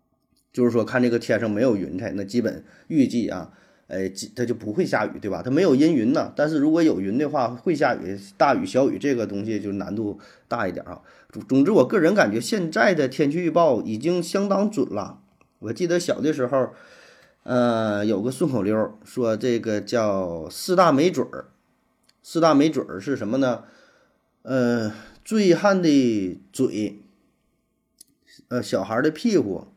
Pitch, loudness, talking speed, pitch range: 120 Hz, -22 LUFS, 255 characters per minute, 105-150 Hz